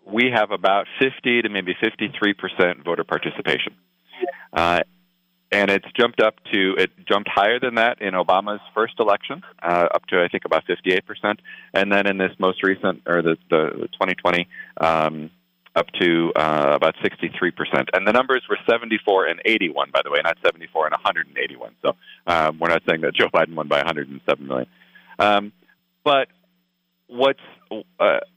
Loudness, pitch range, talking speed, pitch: -21 LUFS, 85-120 Hz, 165 wpm, 100 Hz